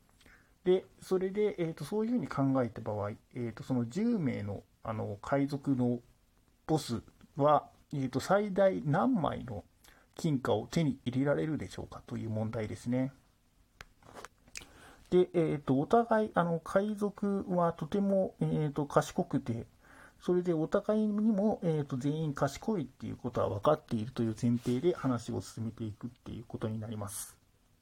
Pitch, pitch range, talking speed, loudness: 135 Hz, 115-175 Hz, 295 characters per minute, -33 LUFS